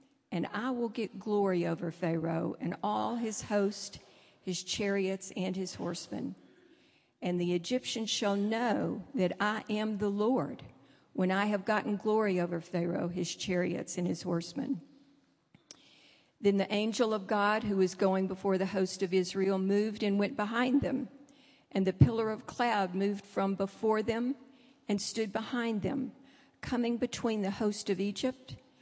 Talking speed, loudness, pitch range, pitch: 155 wpm, -32 LUFS, 190-230 Hz, 205 Hz